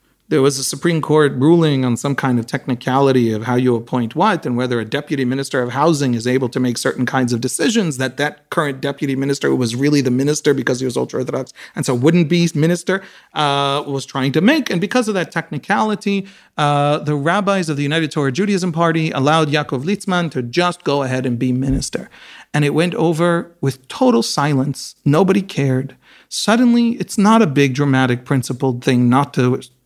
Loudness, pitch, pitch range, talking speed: -17 LUFS, 145 Hz, 130-170 Hz, 195 wpm